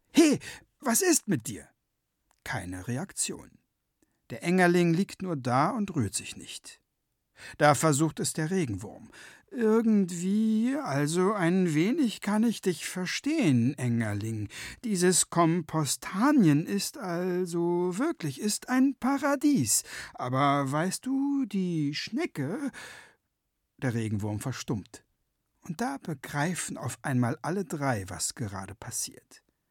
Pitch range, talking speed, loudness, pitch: 130-210 Hz, 115 wpm, -28 LUFS, 170 Hz